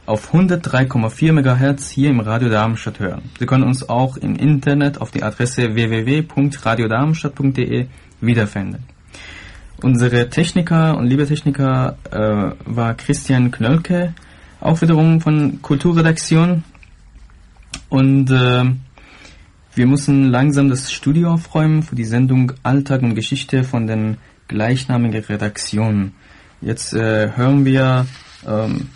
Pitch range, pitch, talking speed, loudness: 115-145 Hz, 130 Hz, 110 wpm, -16 LUFS